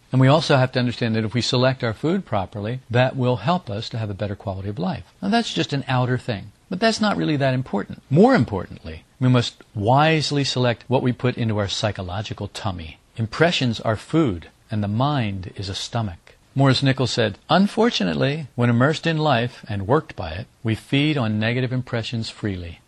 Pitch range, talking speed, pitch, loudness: 105-140 Hz, 200 wpm, 125 Hz, -22 LUFS